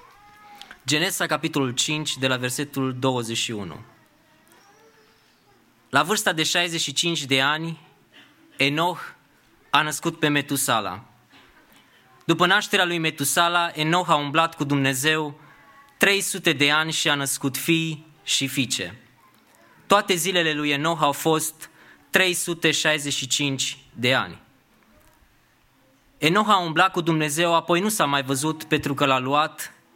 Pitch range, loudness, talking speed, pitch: 140-170 Hz, -22 LUFS, 120 wpm, 155 Hz